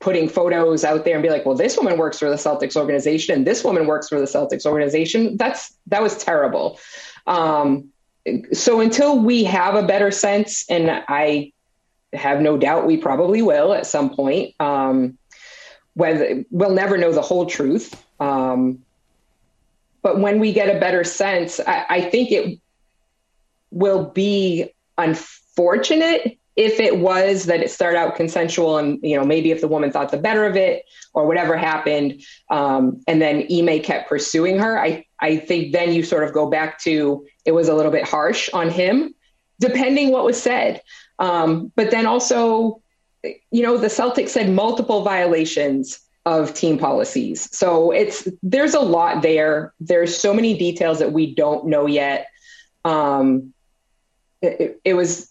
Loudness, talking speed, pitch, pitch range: -18 LUFS, 170 wpm, 170 Hz, 150-210 Hz